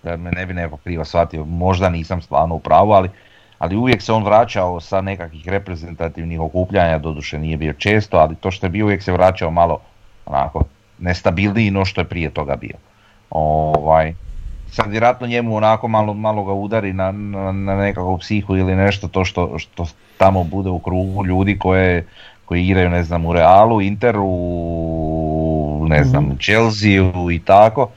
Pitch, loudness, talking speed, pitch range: 90 Hz, -17 LUFS, 170 wpm, 85-100 Hz